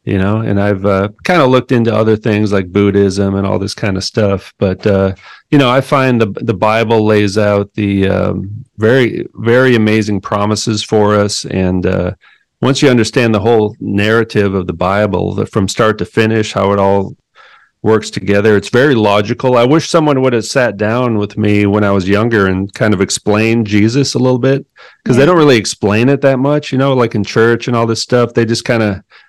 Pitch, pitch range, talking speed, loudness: 110 Hz, 100-120 Hz, 215 wpm, -12 LUFS